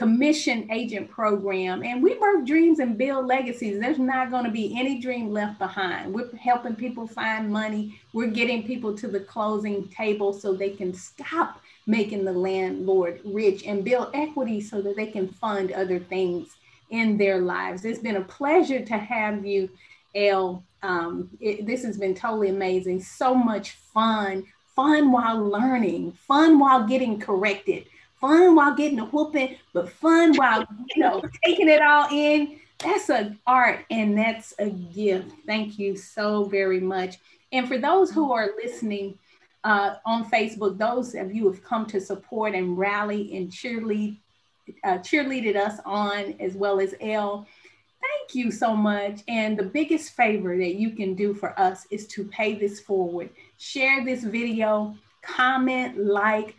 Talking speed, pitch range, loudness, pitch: 165 wpm, 200-255 Hz, -24 LUFS, 215 Hz